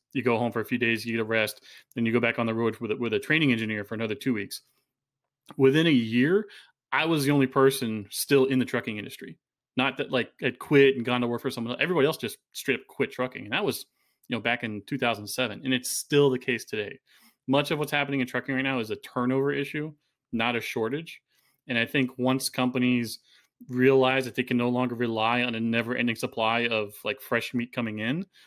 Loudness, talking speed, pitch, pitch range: -26 LUFS, 230 wpm, 125 Hz, 115-135 Hz